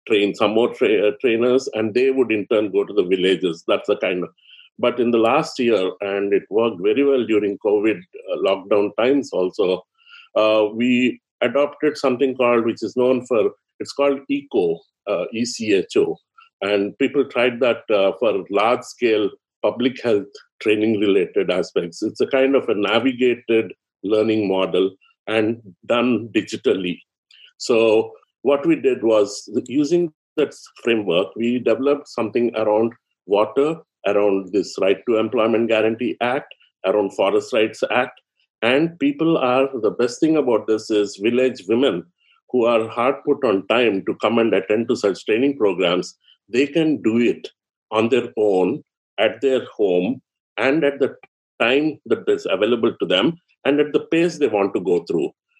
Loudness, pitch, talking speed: -20 LUFS, 140 Hz, 160 wpm